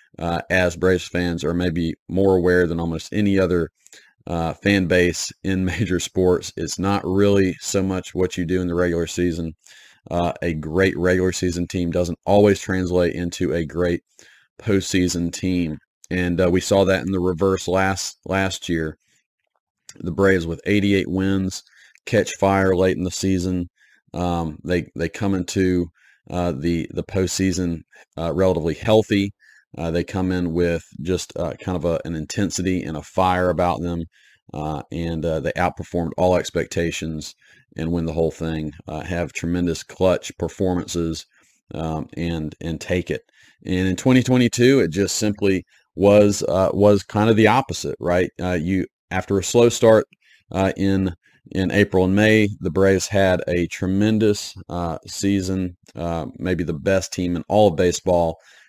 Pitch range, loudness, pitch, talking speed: 85-95 Hz, -21 LUFS, 90 Hz, 165 wpm